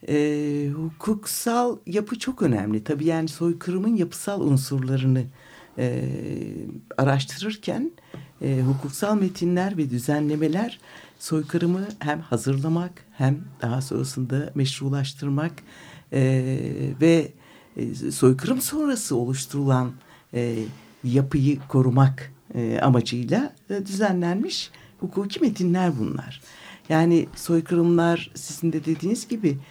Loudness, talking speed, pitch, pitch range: -24 LUFS, 95 wpm, 150 Hz, 135-180 Hz